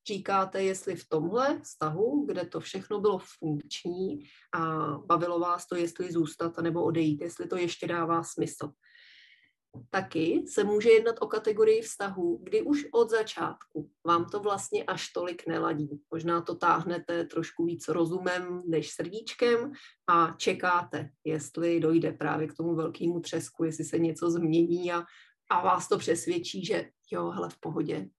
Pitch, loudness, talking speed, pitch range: 170 Hz, -30 LUFS, 150 wpm, 160-200 Hz